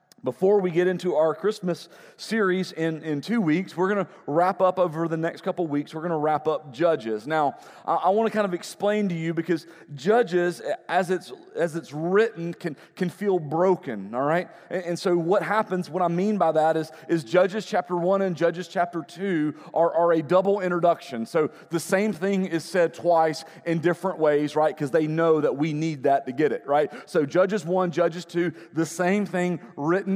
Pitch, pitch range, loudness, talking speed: 170 Hz, 160-185 Hz, -24 LUFS, 205 wpm